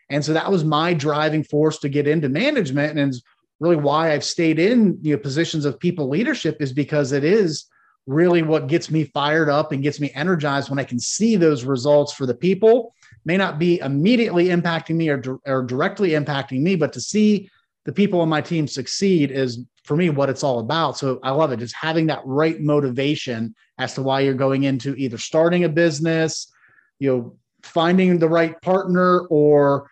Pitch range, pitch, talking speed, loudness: 140-170 Hz, 150 Hz, 200 wpm, -20 LUFS